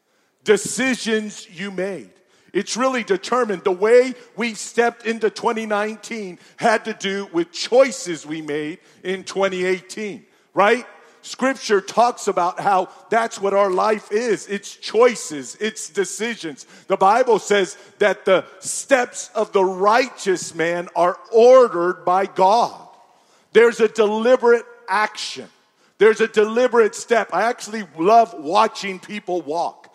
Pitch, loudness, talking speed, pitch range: 210 Hz, -19 LUFS, 125 wpm, 190-235 Hz